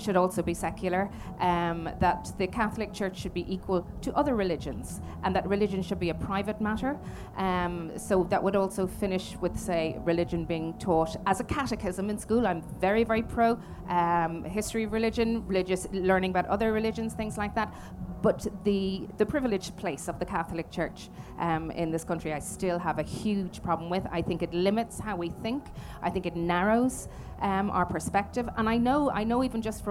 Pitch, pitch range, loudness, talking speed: 190 Hz, 175-215 Hz, -30 LUFS, 195 wpm